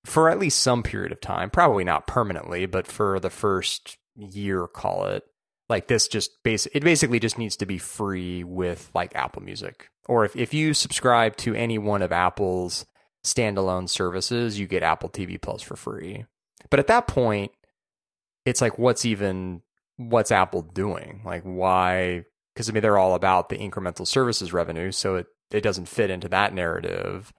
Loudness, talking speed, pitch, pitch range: -24 LUFS, 180 wpm, 100 Hz, 90-120 Hz